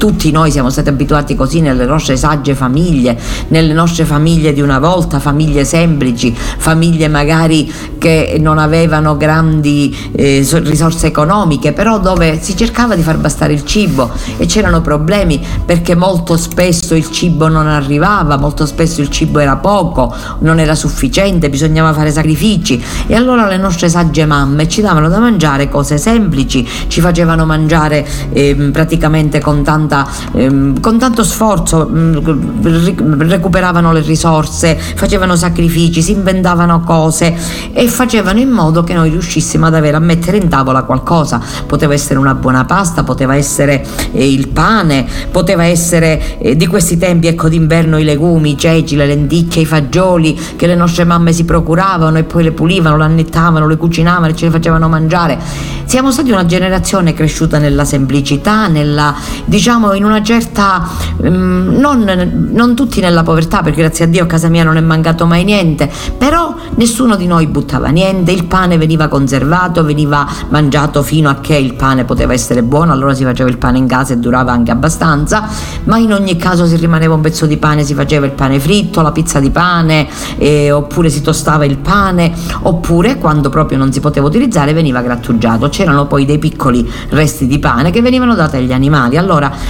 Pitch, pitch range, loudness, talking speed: 160 Hz, 145-175 Hz, -10 LUFS, 170 wpm